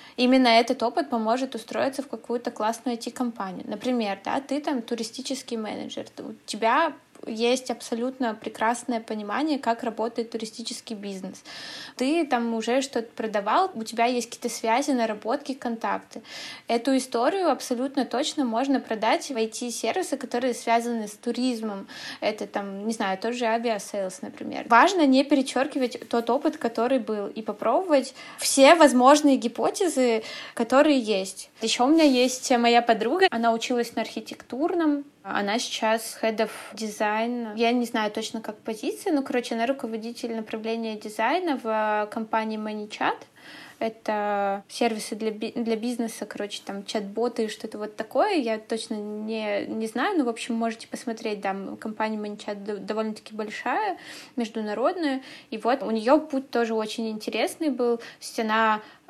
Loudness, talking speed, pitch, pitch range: -25 LUFS, 145 wpm, 235 Hz, 225-265 Hz